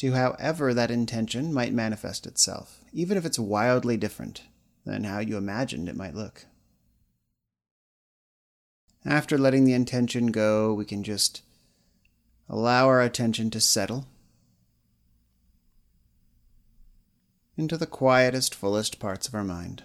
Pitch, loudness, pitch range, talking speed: 115 Hz, -25 LUFS, 105-130 Hz, 120 wpm